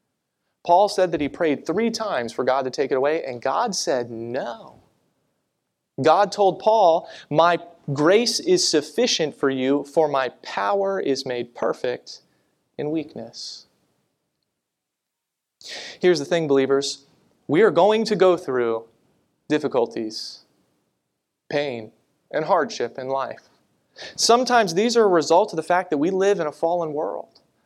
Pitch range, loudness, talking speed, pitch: 135-195 Hz, -21 LUFS, 140 wpm, 160 Hz